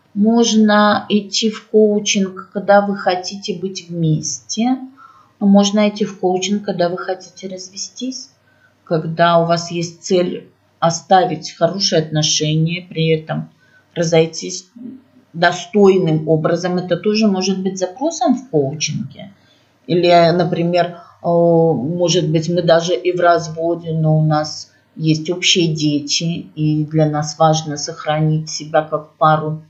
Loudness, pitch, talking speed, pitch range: -16 LUFS, 175 Hz, 125 wpm, 160-195 Hz